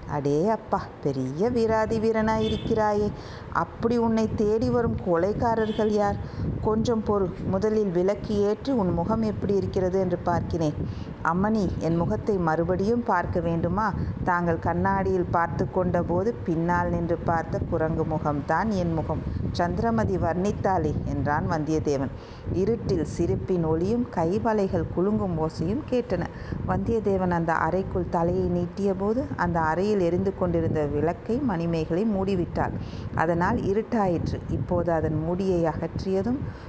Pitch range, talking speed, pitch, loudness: 165-210 Hz, 110 wpm, 180 Hz, -26 LUFS